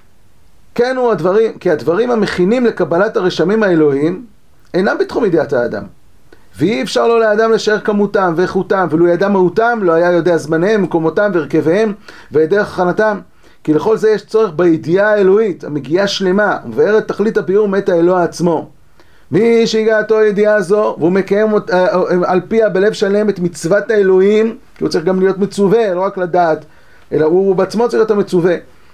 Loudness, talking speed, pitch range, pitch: -13 LUFS, 155 wpm, 180-215 Hz, 200 Hz